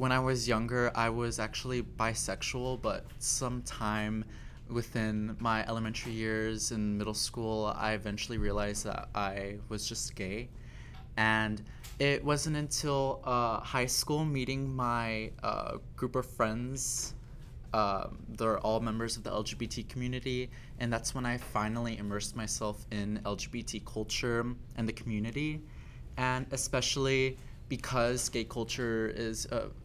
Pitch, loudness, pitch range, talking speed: 115 Hz, -34 LUFS, 110-125 Hz, 135 wpm